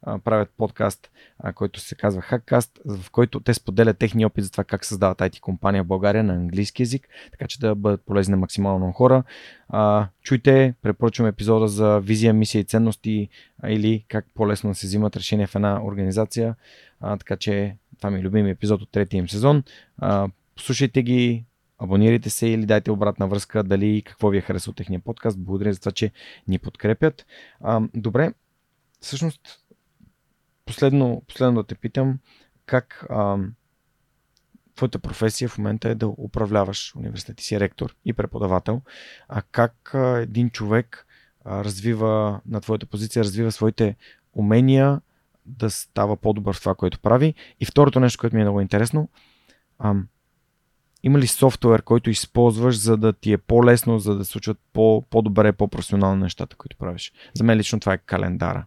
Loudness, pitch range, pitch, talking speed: -21 LUFS, 100-120 Hz, 110 Hz, 160 wpm